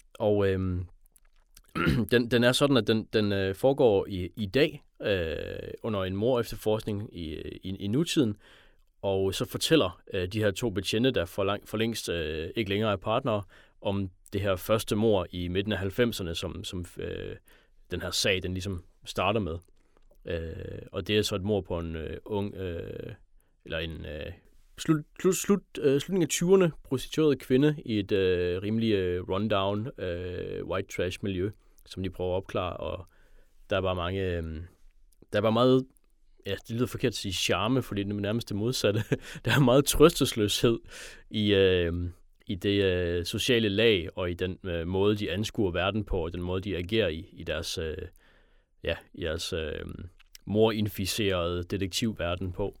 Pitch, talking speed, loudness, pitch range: 100 Hz, 175 wpm, -28 LUFS, 90-115 Hz